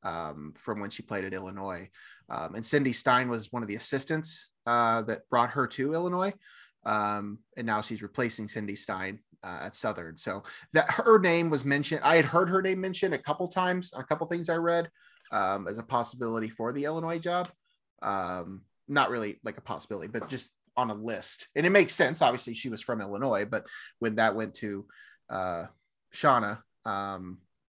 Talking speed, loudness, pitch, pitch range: 190 wpm, -29 LUFS, 120 Hz, 105-165 Hz